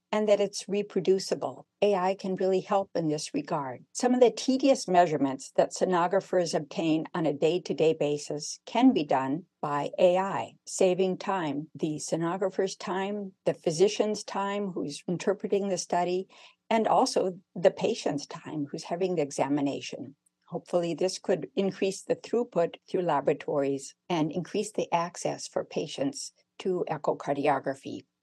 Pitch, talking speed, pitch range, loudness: 185 Hz, 140 wpm, 160-200 Hz, -29 LUFS